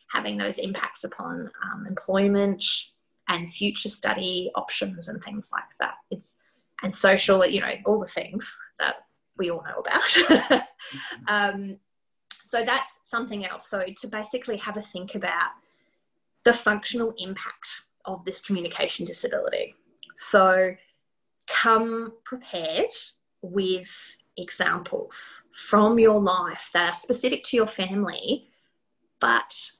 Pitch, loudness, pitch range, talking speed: 205 Hz, -25 LUFS, 190-230 Hz, 125 wpm